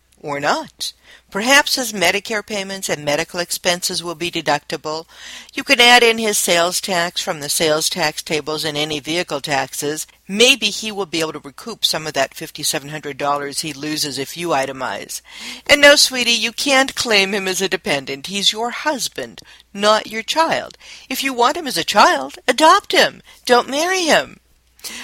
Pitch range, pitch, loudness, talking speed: 155-240 Hz, 185 Hz, -16 LUFS, 180 wpm